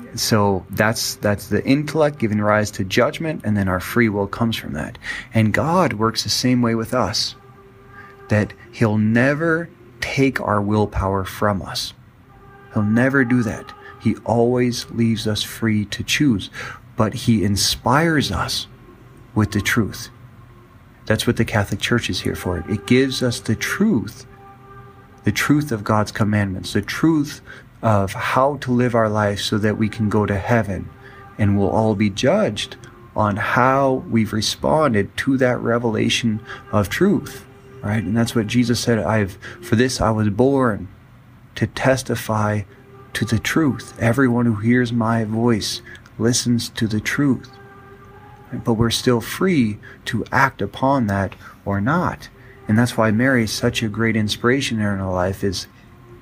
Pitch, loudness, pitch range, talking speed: 115 Hz, -19 LUFS, 105-125 Hz, 160 wpm